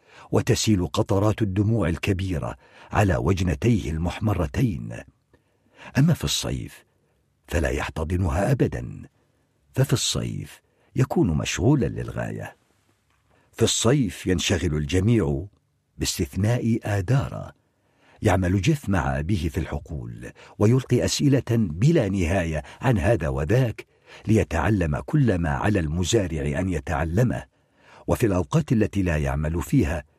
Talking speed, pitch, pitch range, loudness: 100 wpm, 100 Hz, 85-120 Hz, -24 LUFS